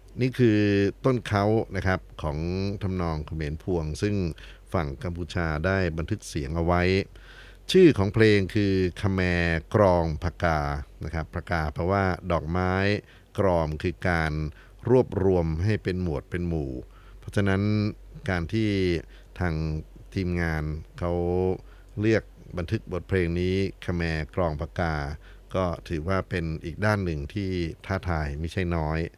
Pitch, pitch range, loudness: 90 Hz, 85-100 Hz, -26 LUFS